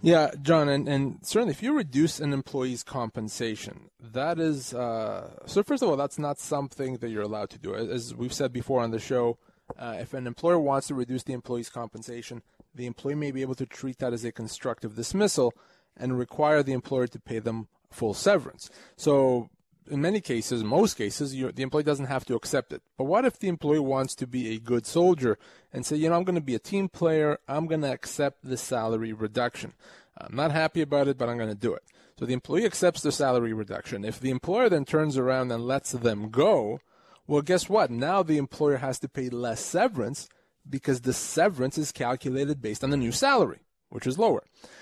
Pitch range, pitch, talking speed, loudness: 120-150 Hz, 135 Hz, 210 wpm, -27 LUFS